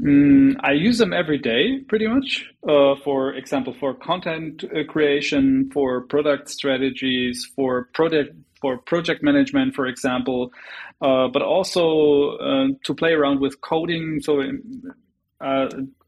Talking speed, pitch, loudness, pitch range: 135 wpm, 145 Hz, -20 LUFS, 135-190 Hz